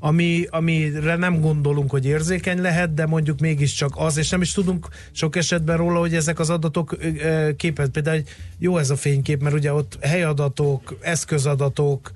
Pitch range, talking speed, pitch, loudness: 145-170 Hz, 165 wpm, 160 Hz, -21 LUFS